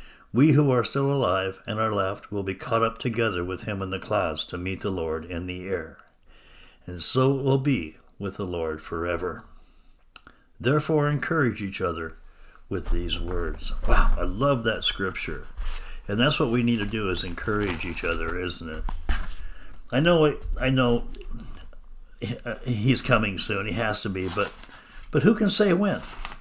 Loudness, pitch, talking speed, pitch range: -26 LUFS, 100 Hz, 175 wpm, 90-130 Hz